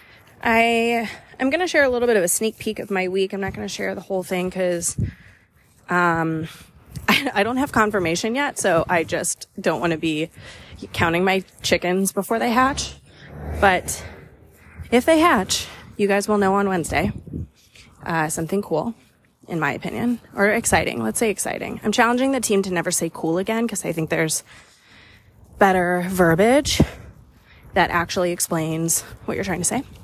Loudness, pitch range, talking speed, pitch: -21 LUFS, 165-225 Hz, 175 wpm, 185 Hz